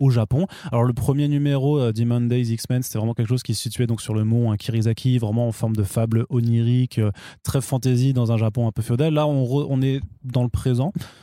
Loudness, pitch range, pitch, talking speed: -22 LUFS, 115-135 Hz, 120 Hz, 235 wpm